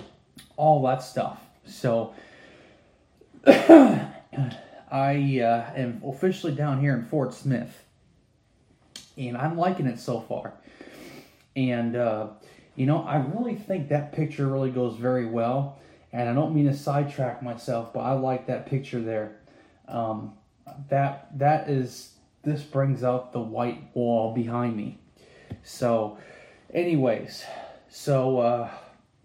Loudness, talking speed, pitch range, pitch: -25 LUFS, 125 wpm, 120-145 Hz, 130 Hz